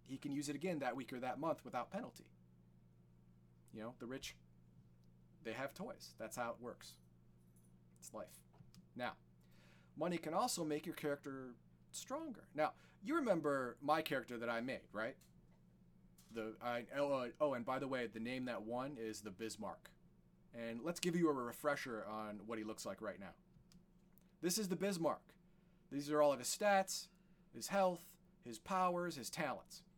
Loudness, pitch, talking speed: -43 LUFS, 125 Hz, 170 wpm